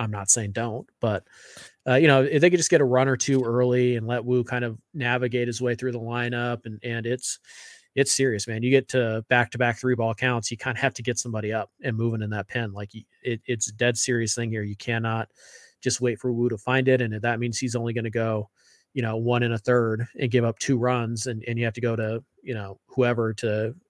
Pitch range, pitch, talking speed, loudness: 115-125 Hz, 120 Hz, 265 wpm, -25 LUFS